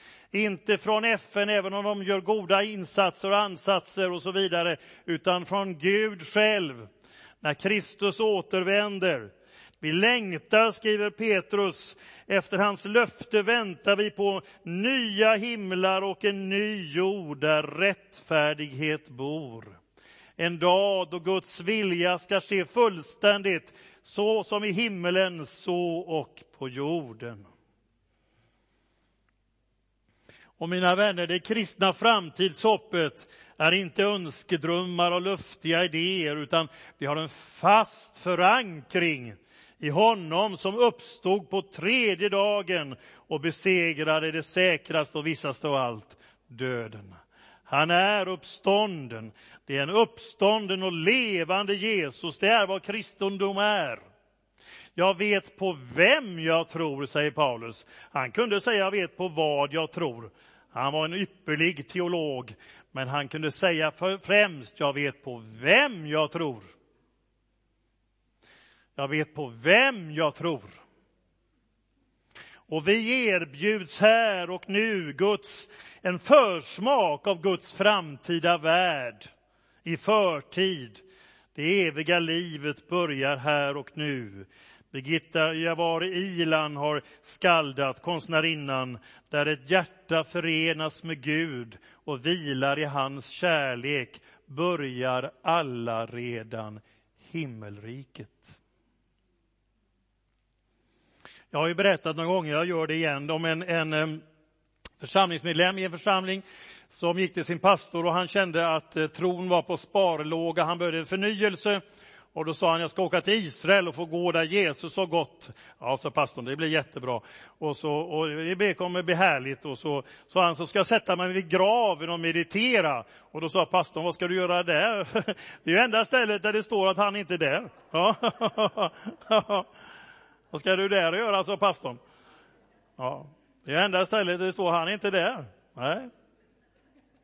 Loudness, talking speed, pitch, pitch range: -26 LUFS, 135 wpm, 175 Hz, 150-195 Hz